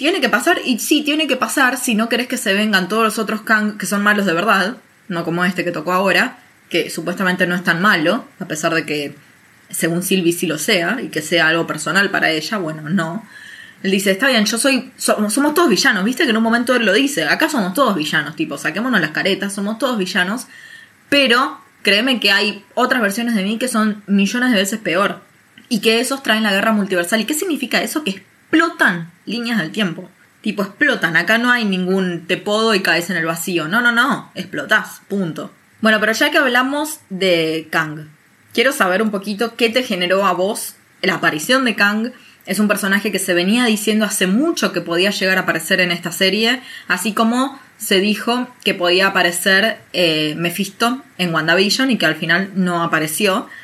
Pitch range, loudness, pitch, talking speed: 180-235 Hz, -16 LUFS, 205 Hz, 205 wpm